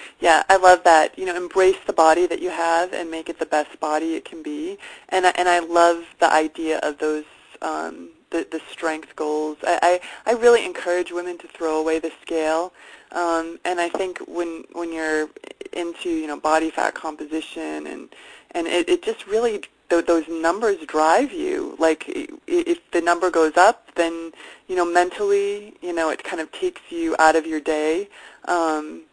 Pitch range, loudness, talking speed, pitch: 160-190 Hz, -21 LUFS, 185 wpm, 170 Hz